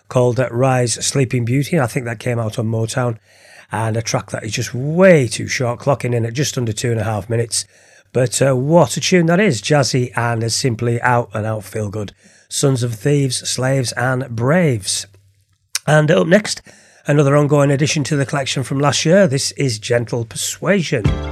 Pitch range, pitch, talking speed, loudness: 115-145 Hz, 125 Hz, 190 wpm, -17 LUFS